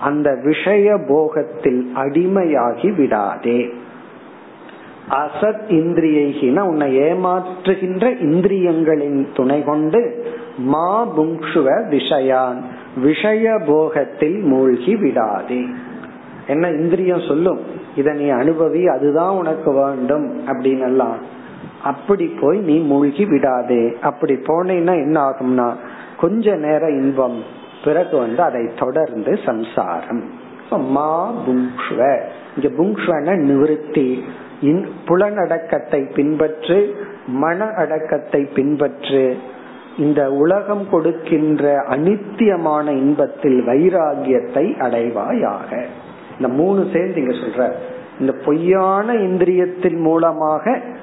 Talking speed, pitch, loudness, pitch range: 80 wpm, 155 Hz, -17 LUFS, 140-180 Hz